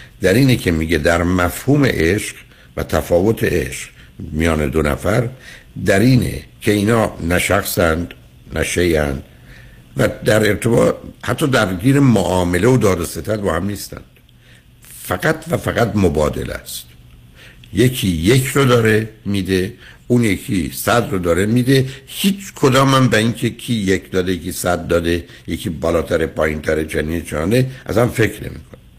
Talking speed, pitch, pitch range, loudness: 145 wpm, 100 Hz, 85-120 Hz, -17 LUFS